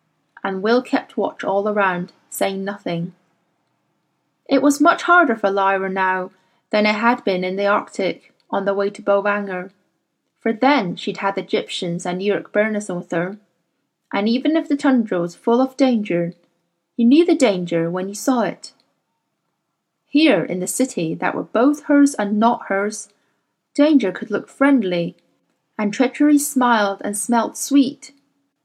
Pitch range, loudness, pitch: 185-265 Hz, -19 LUFS, 210 Hz